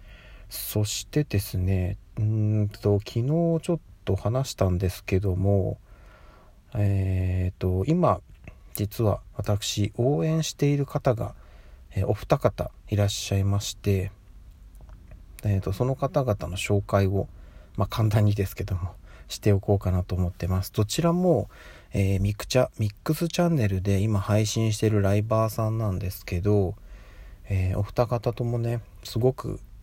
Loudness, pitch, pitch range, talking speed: -26 LUFS, 100 Hz, 95-110 Hz, 280 characters per minute